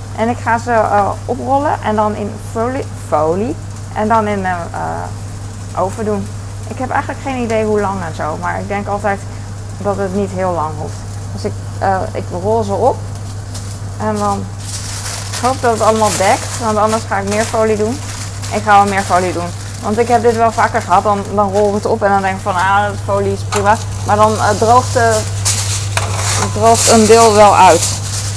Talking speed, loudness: 205 wpm, -14 LUFS